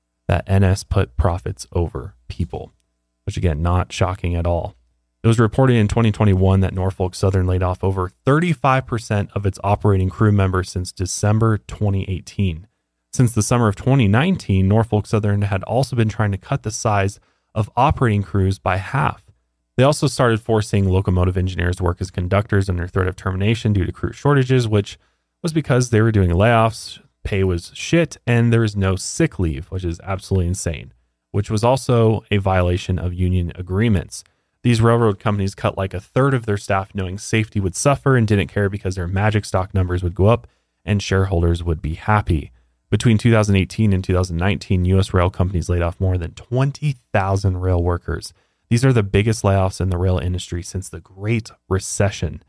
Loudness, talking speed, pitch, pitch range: -19 LUFS, 175 wpm, 95 Hz, 90-110 Hz